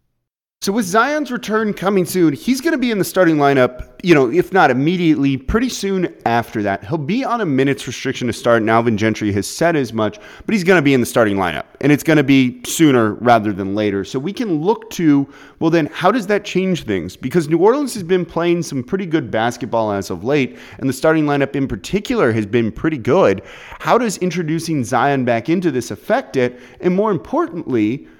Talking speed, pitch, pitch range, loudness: 220 wpm, 145 Hz, 120-180 Hz, -17 LUFS